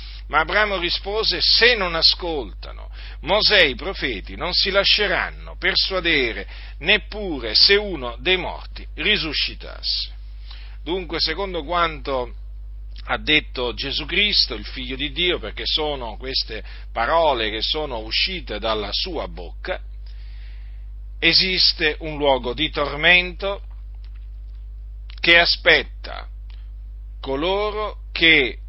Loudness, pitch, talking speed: -19 LUFS, 135 Hz, 105 wpm